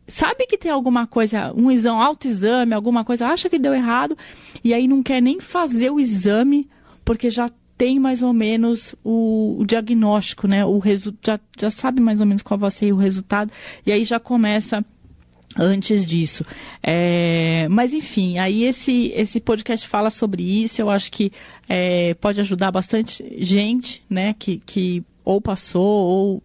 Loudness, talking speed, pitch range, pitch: -19 LUFS, 170 wpm, 200-245 Hz, 220 Hz